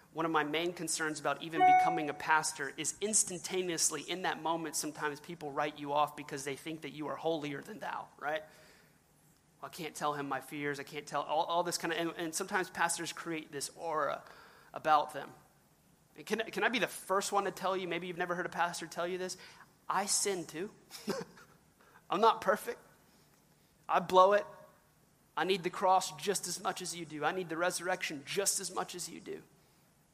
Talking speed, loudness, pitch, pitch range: 205 wpm, -34 LUFS, 170 Hz, 155-185 Hz